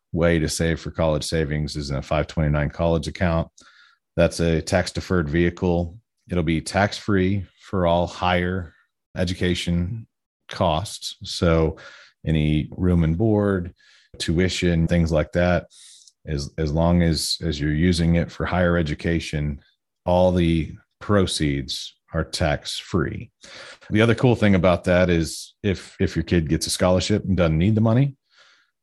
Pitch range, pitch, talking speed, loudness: 80-90 Hz, 85 Hz, 150 wpm, -22 LUFS